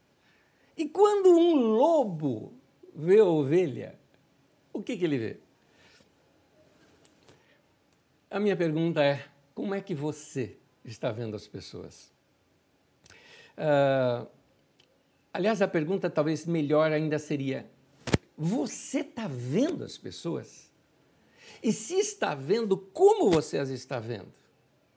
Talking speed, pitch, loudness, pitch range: 110 wpm, 160 Hz, -28 LUFS, 140-220 Hz